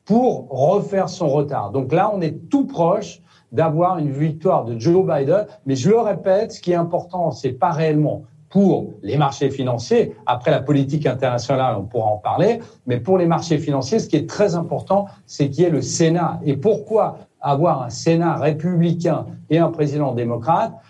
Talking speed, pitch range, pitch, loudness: 185 wpm, 140-180 Hz, 160 Hz, -19 LUFS